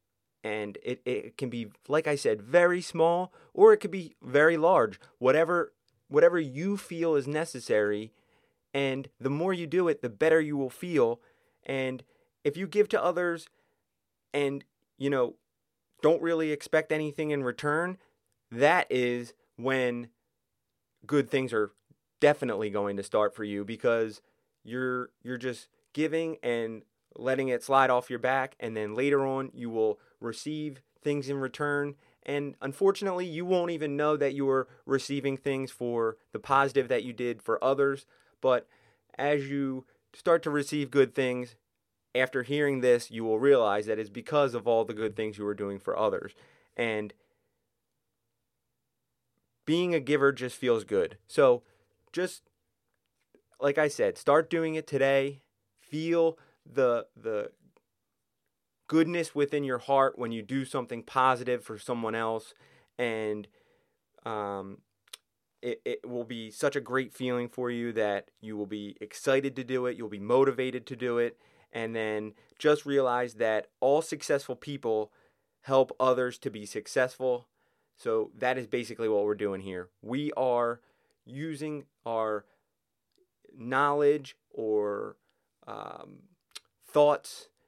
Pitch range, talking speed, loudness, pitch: 115-150 Hz, 145 wpm, -29 LUFS, 130 Hz